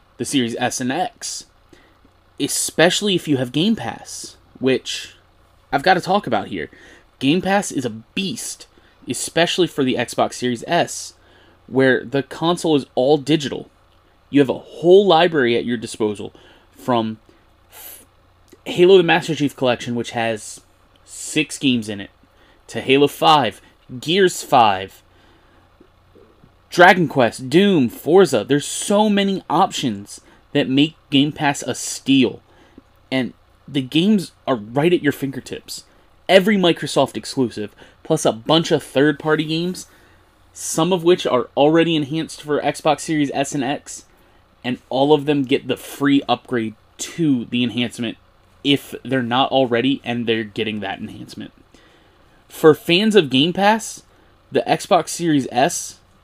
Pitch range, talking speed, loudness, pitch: 115-160 Hz, 145 wpm, -18 LUFS, 135 Hz